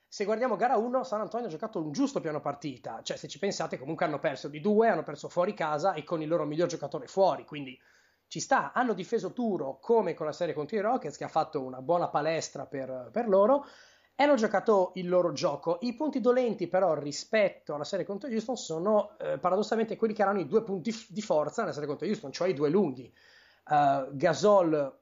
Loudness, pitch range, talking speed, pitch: -29 LUFS, 150-215 Hz, 220 wpm, 180 Hz